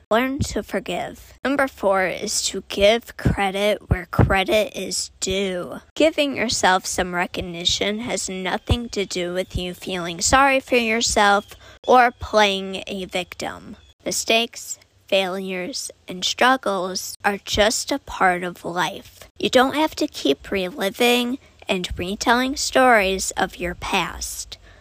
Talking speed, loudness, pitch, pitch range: 130 wpm, -21 LUFS, 200 Hz, 185-240 Hz